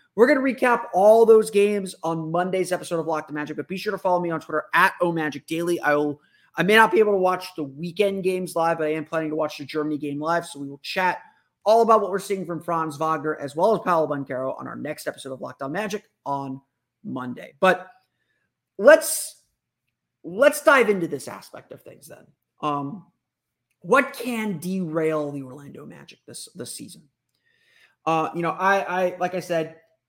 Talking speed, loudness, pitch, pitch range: 205 wpm, -22 LUFS, 170 Hz, 155-200 Hz